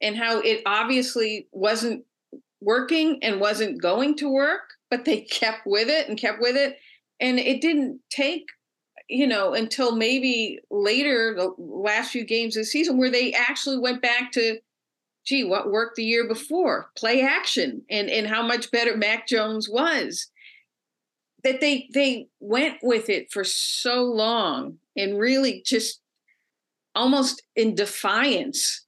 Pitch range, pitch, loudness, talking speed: 225-275 Hz, 245 Hz, -23 LUFS, 150 wpm